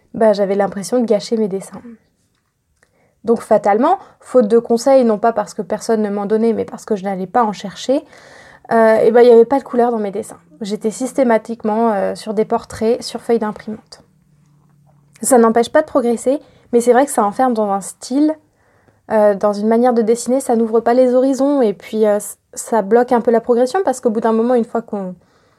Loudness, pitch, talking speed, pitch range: -15 LUFS, 230 Hz, 215 wpm, 215-245 Hz